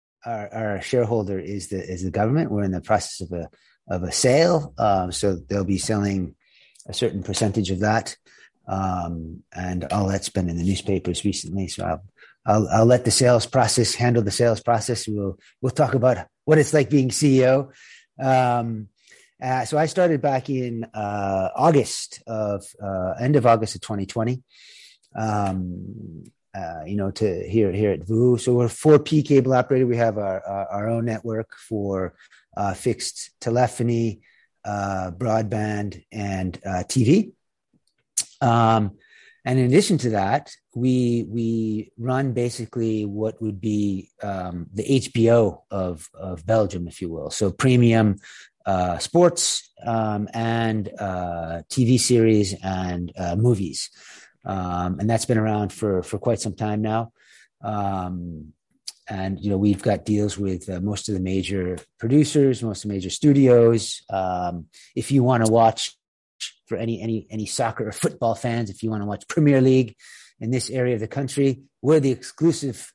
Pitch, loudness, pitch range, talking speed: 110 Hz, -22 LUFS, 95-120 Hz, 165 wpm